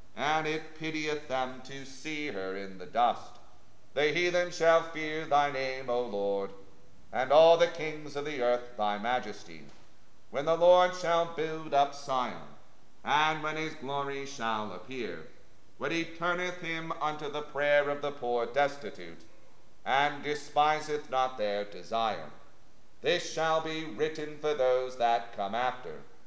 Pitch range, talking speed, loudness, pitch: 120-155 Hz, 150 wpm, -30 LUFS, 145 Hz